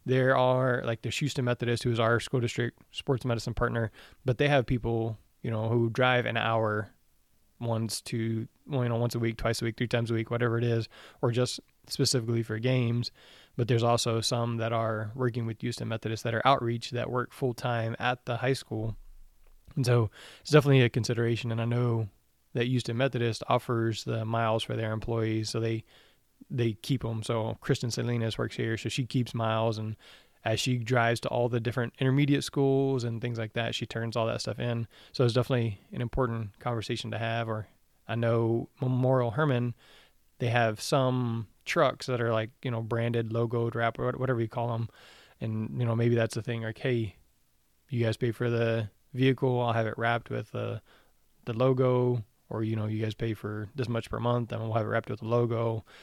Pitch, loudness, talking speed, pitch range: 115 Hz, -30 LUFS, 205 wpm, 115-125 Hz